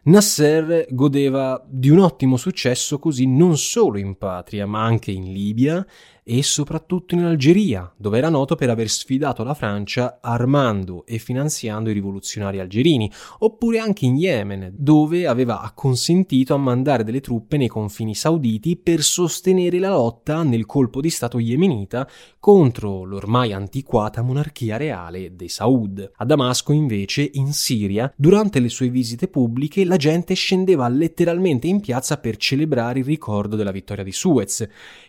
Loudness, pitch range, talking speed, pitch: -19 LUFS, 110-155 Hz, 150 wpm, 130 Hz